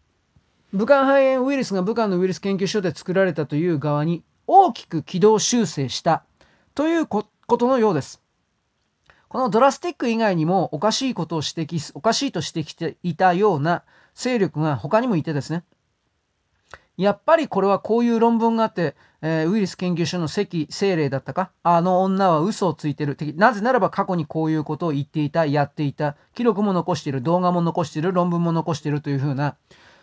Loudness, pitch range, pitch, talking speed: -21 LUFS, 160-220 Hz, 180 Hz, 390 characters per minute